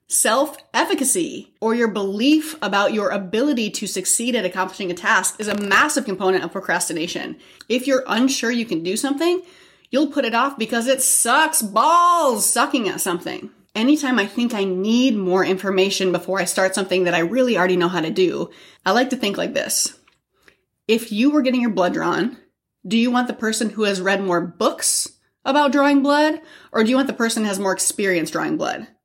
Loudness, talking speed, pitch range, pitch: -19 LUFS, 195 wpm, 195-275 Hz, 225 Hz